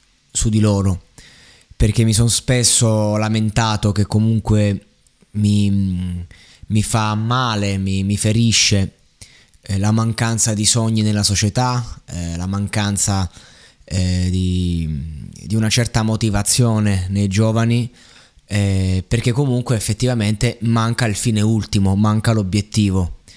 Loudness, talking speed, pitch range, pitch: -17 LUFS, 115 wpm, 95-115 Hz, 105 Hz